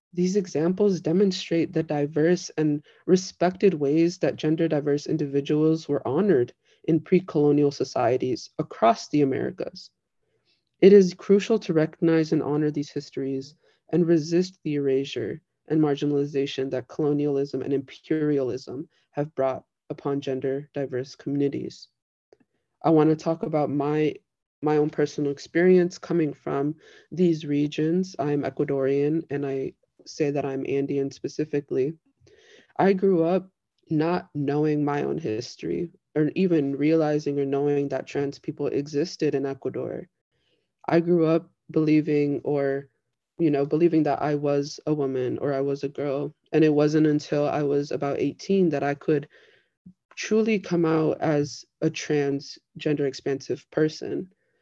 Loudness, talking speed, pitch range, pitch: -25 LUFS, 135 wpm, 140-165 Hz, 150 Hz